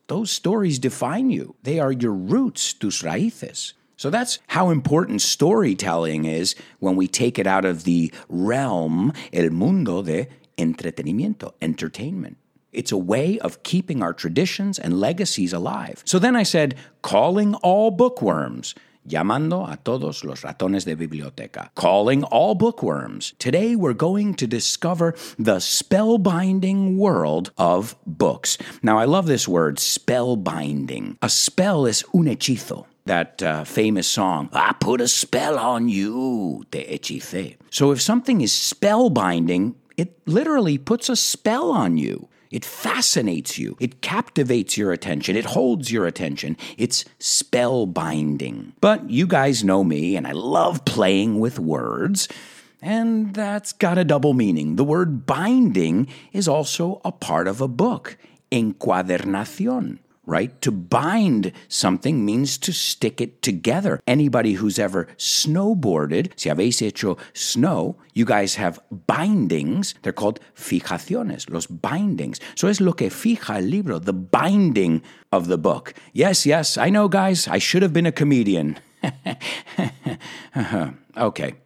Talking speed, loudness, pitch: 140 wpm, -21 LUFS, 145 Hz